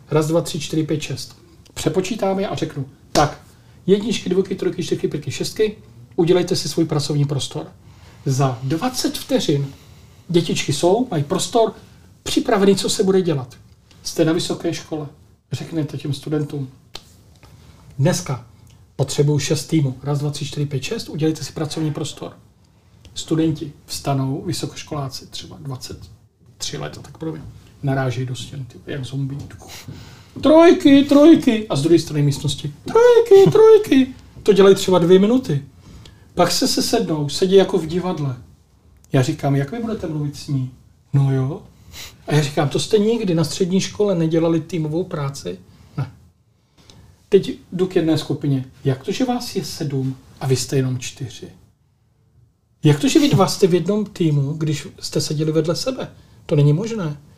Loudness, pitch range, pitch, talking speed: -19 LUFS, 130-180 Hz, 150 Hz, 155 wpm